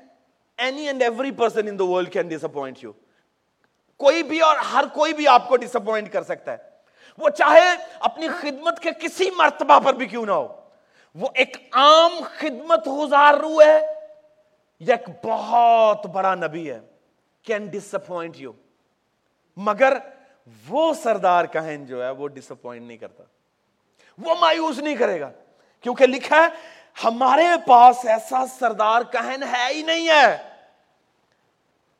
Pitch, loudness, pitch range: 265 Hz, -19 LUFS, 215-310 Hz